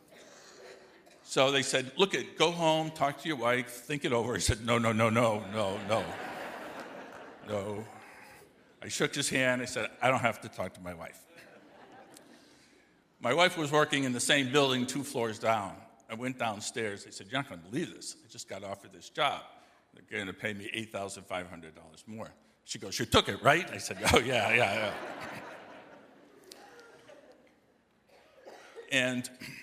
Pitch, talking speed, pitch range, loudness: 125 Hz, 170 wpm, 110-140 Hz, -30 LUFS